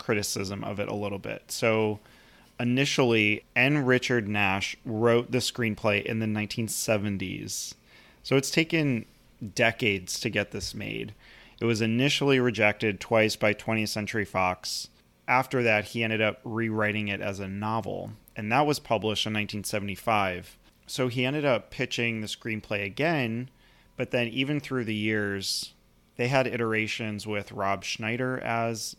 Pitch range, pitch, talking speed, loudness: 105-125 Hz, 110 Hz, 145 wpm, -27 LUFS